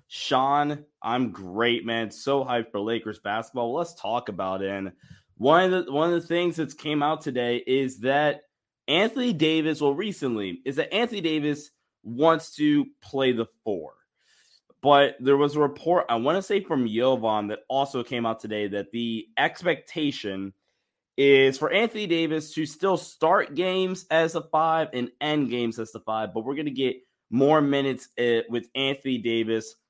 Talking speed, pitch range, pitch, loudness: 175 wpm, 115-160 Hz, 140 Hz, -25 LUFS